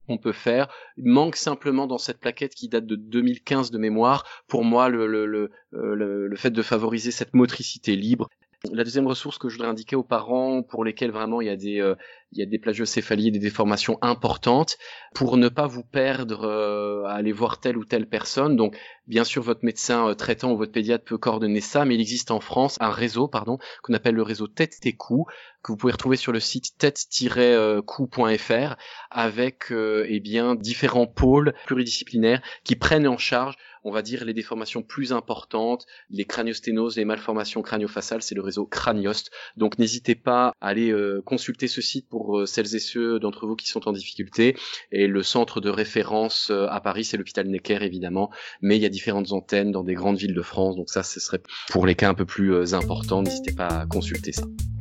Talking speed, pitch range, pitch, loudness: 205 wpm, 105-120 Hz, 115 Hz, -24 LUFS